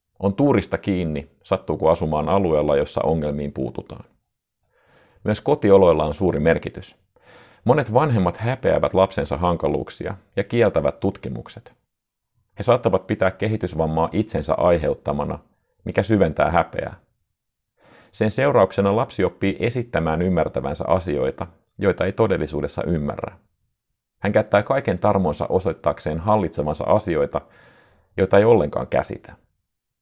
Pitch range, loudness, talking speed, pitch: 80-105 Hz, -21 LUFS, 105 wpm, 95 Hz